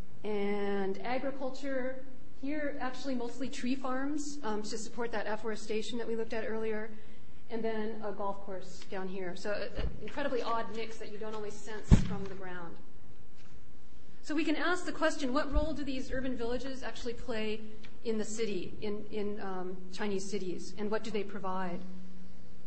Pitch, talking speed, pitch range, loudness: 220 Hz, 170 wpm, 205-255 Hz, -37 LUFS